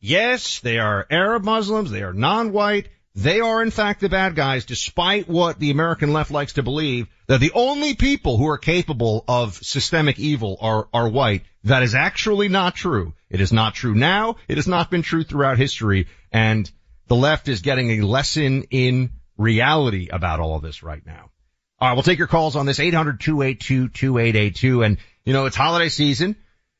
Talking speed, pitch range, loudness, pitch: 185 wpm, 110-165 Hz, -19 LUFS, 135 Hz